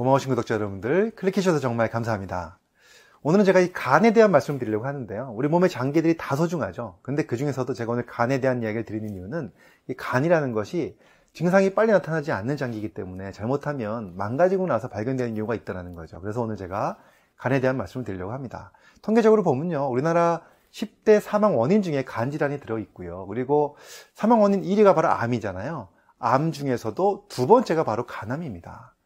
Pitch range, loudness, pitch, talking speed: 110-175 Hz, -24 LUFS, 130 Hz, 435 characters per minute